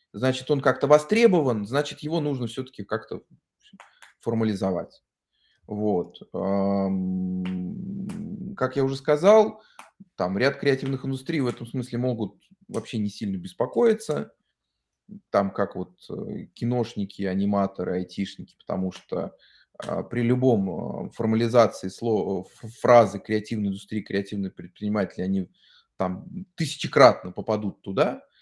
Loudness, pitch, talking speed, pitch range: -25 LUFS, 120 Hz, 105 wpm, 100-150 Hz